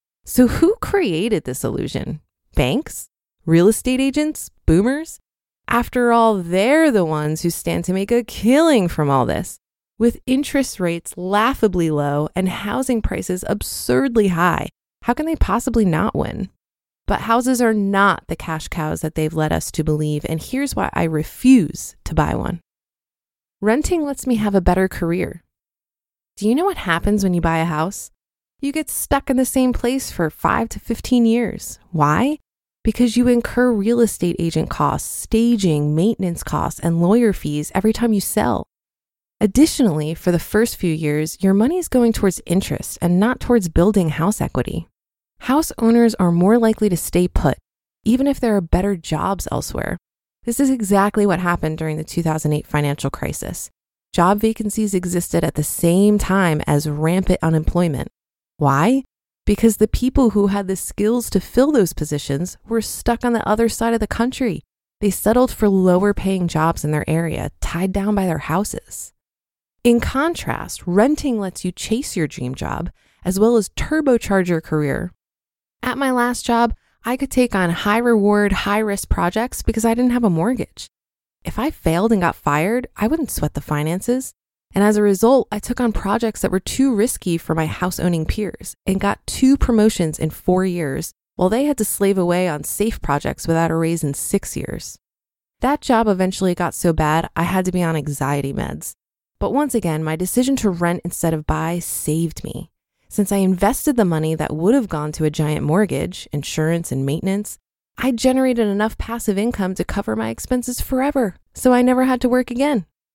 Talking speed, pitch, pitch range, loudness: 180 wpm, 200 Hz, 165-235 Hz, -19 LUFS